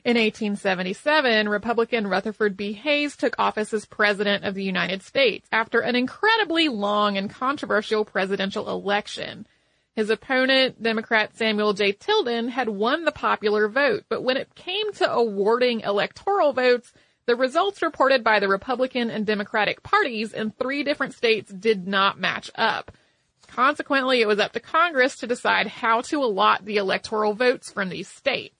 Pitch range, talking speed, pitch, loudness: 210-265 Hz, 155 wpm, 230 Hz, -22 LUFS